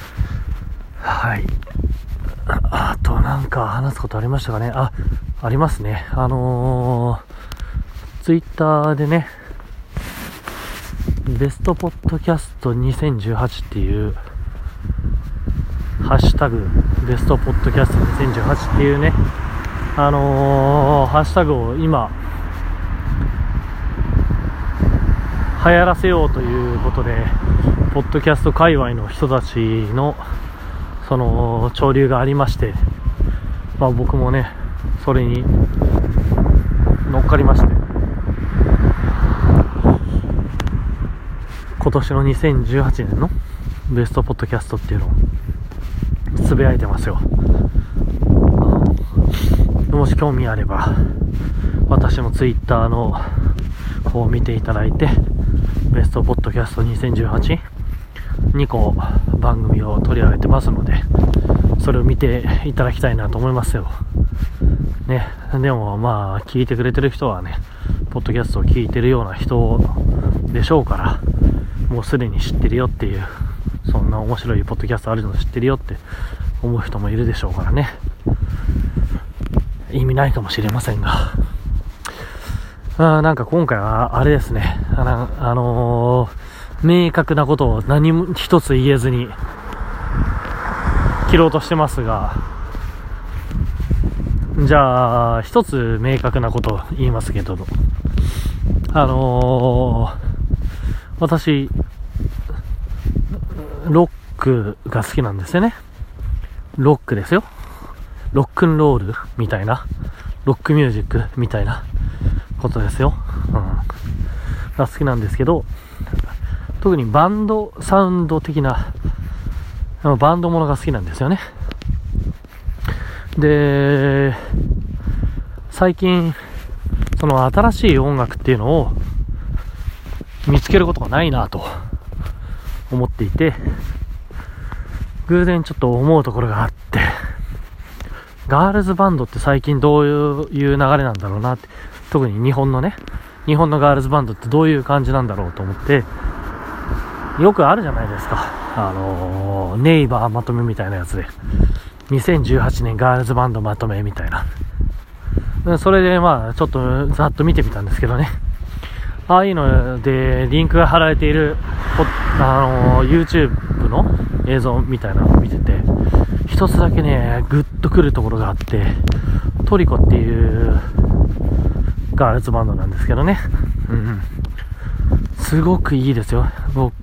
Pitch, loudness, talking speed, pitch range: 110 Hz, -17 LUFS, 245 characters per minute, 90-135 Hz